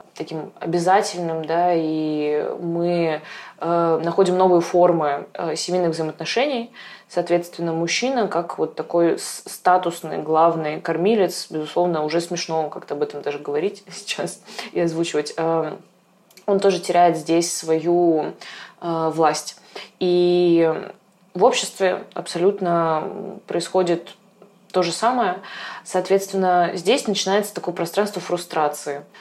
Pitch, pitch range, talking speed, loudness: 175 Hz, 165-185 Hz, 110 wpm, -21 LUFS